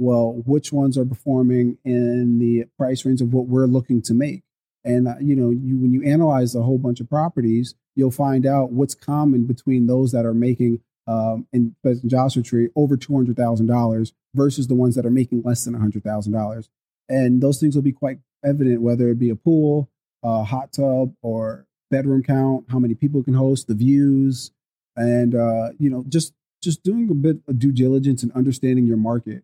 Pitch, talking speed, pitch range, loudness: 125 Hz, 195 wpm, 120-135 Hz, -20 LUFS